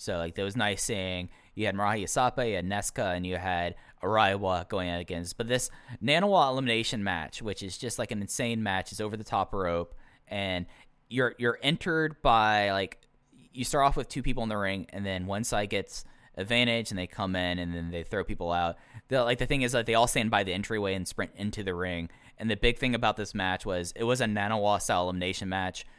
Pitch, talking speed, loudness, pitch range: 105 Hz, 230 wpm, -29 LUFS, 90-120 Hz